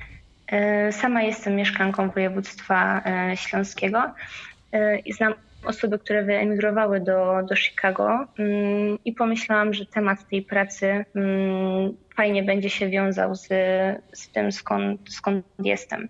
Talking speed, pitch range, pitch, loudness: 110 wpm, 190-210 Hz, 195 Hz, -23 LUFS